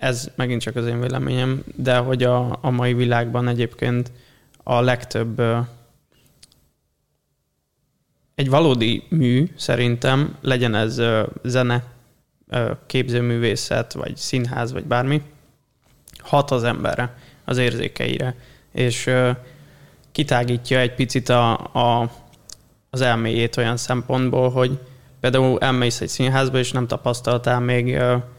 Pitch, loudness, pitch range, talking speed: 125 Hz, -21 LUFS, 120-130 Hz, 120 wpm